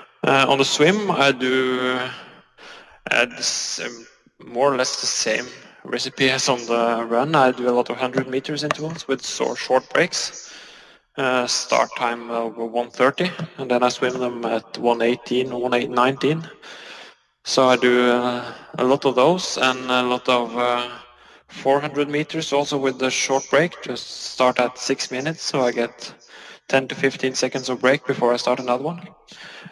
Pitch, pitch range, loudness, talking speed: 130 Hz, 125-135 Hz, -21 LUFS, 165 wpm